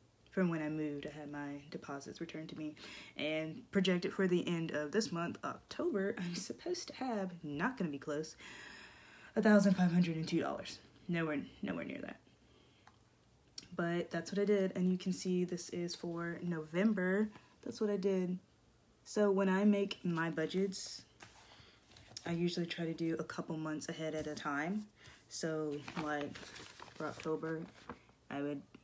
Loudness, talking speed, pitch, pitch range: -38 LUFS, 165 wpm, 170 Hz, 150-190 Hz